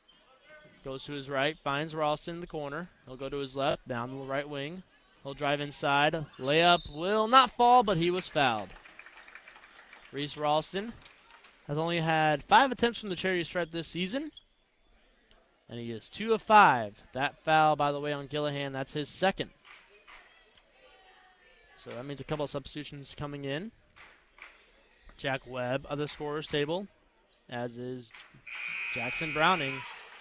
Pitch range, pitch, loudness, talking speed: 135-170 Hz, 150 Hz, -29 LUFS, 155 wpm